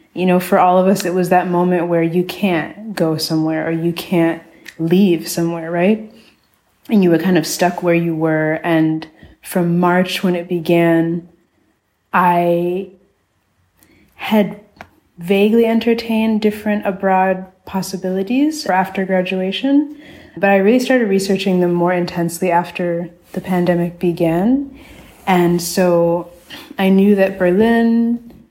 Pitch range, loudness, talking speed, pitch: 170-200 Hz, -16 LUFS, 135 wpm, 180 Hz